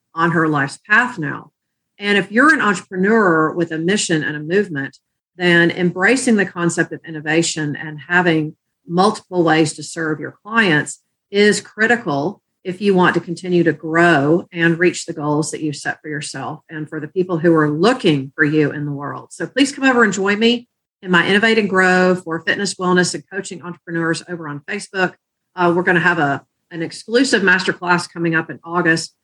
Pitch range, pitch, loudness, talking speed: 155-195 Hz, 175 Hz, -17 LUFS, 195 wpm